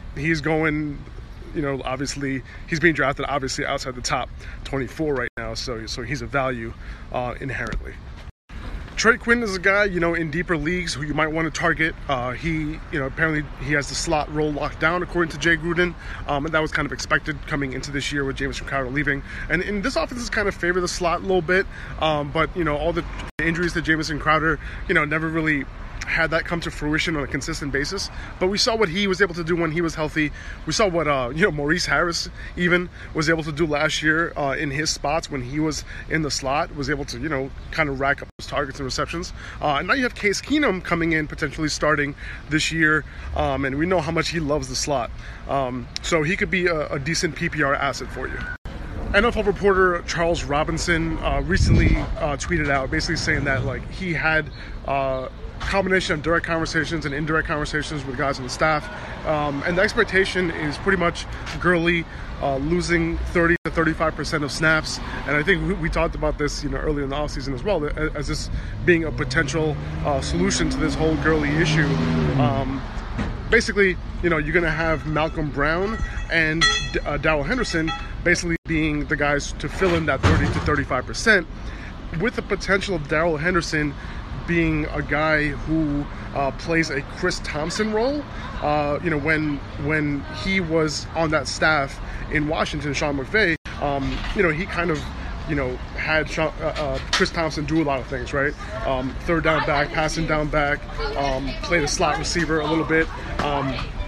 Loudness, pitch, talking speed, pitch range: -22 LUFS, 155 Hz, 205 wpm, 140-170 Hz